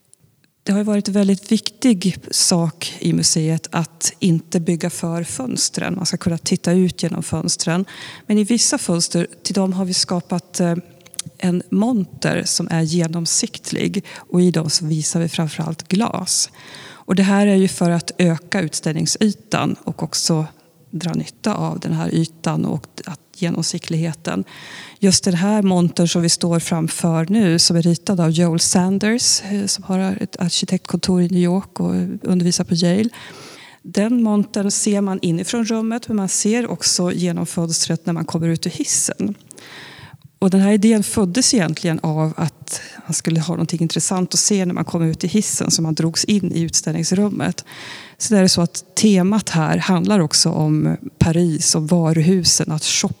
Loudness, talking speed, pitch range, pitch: -18 LUFS, 170 wpm, 165-195 Hz, 175 Hz